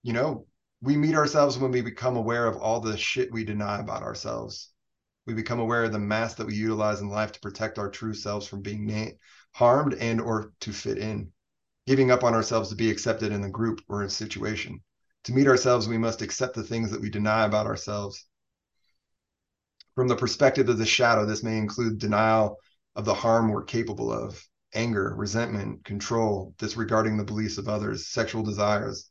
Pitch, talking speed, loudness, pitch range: 110 Hz, 195 wpm, -26 LUFS, 105-115 Hz